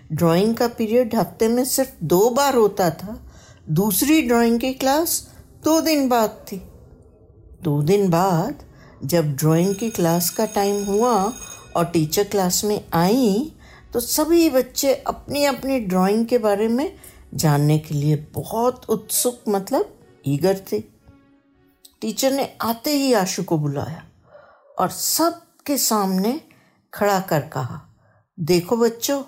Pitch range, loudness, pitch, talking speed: 165-250 Hz, -20 LUFS, 205 Hz, 135 wpm